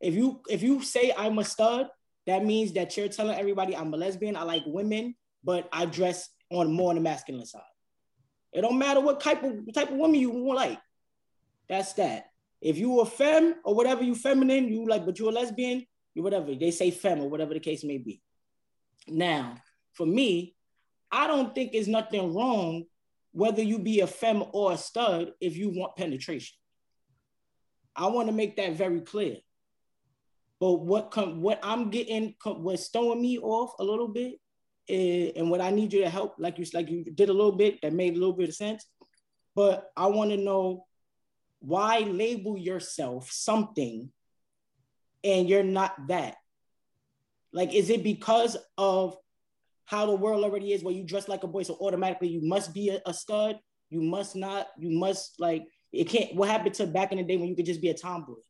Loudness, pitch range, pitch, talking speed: -28 LUFS, 175-220 Hz, 195 Hz, 195 wpm